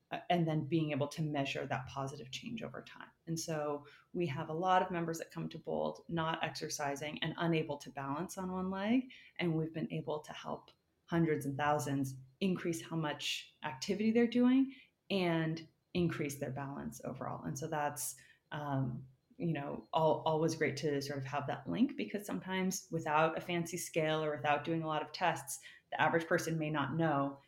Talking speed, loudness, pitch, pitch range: 190 wpm, -37 LUFS, 160 Hz, 145-170 Hz